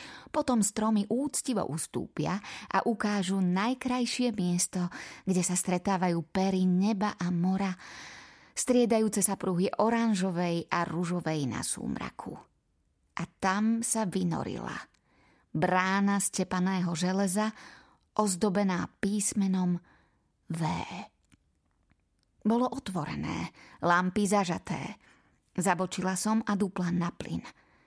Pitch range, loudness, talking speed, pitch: 175-210 Hz, -30 LUFS, 95 wpm, 190 Hz